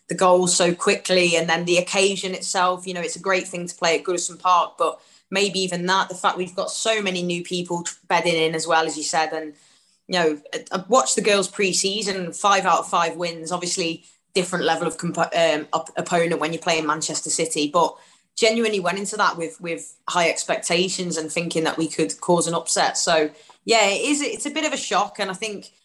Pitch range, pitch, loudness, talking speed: 165-195 Hz, 175 Hz, -21 LUFS, 225 wpm